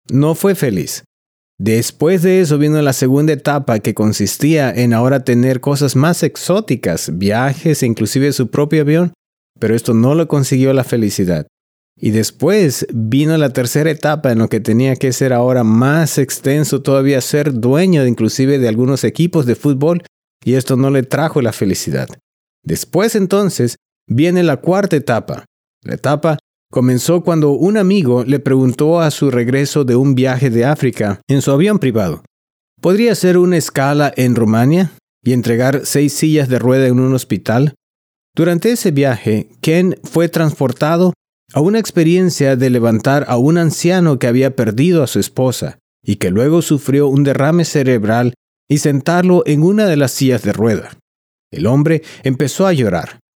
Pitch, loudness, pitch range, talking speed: 140 Hz, -14 LUFS, 125-160 Hz, 165 wpm